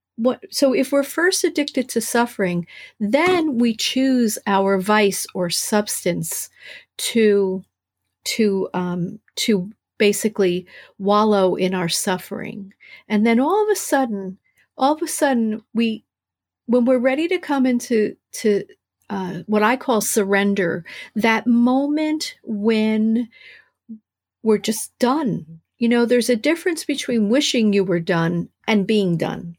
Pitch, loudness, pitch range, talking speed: 220 Hz, -20 LUFS, 195-255 Hz, 135 wpm